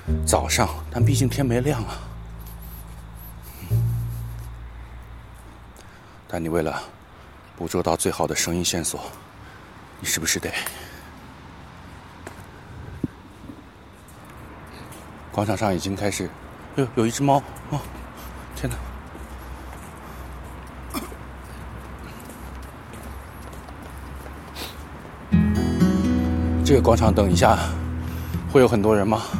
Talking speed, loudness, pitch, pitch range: 115 characters per minute, -23 LUFS, 85 Hz, 75-100 Hz